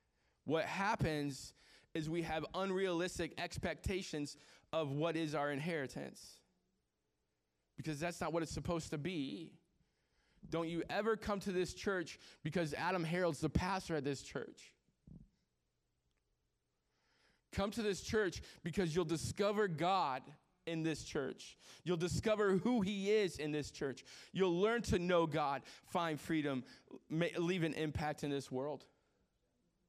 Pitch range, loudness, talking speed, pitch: 145-185 Hz, -39 LUFS, 135 wpm, 165 Hz